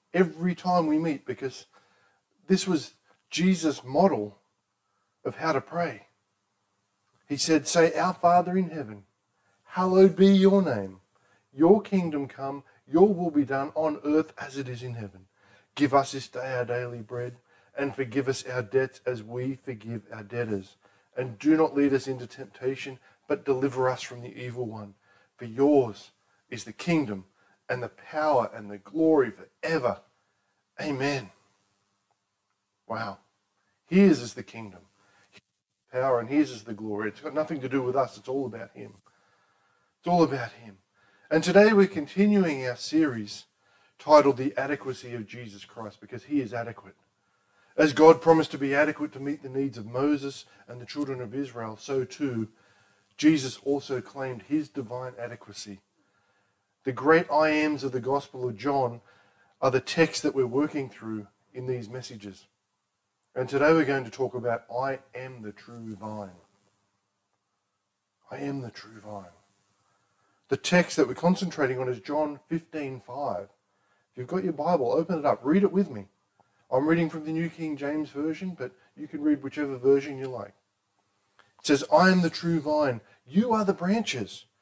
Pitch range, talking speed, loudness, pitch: 100-145 Hz, 165 wpm, -26 LUFS, 125 Hz